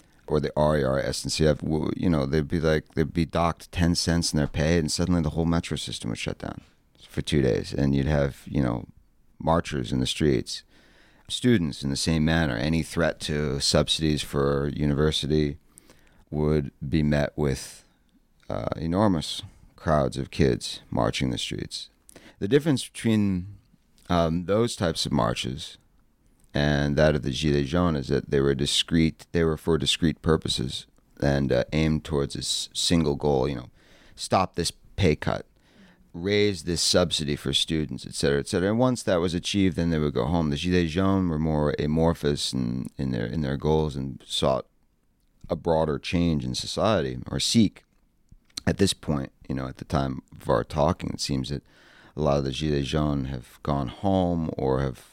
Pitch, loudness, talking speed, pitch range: 75 Hz, -25 LUFS, 180 wpm, 70-85 Hz